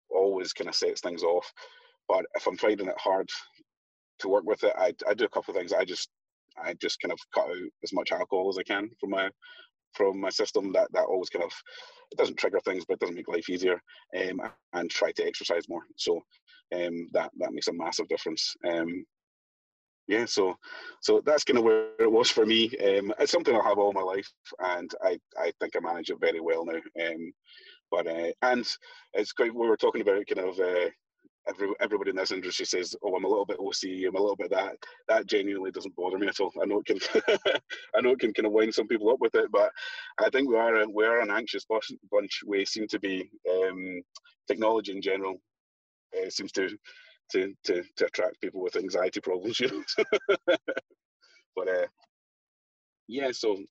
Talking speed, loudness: 210 wpm, -29 LUFS